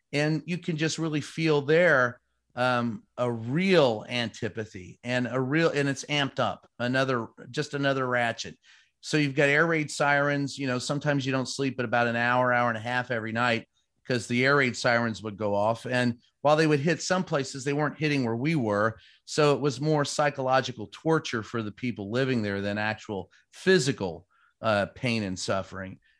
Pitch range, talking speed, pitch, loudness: 115-145 Hz, 190 wpm, 130 Hz, -27 LUFS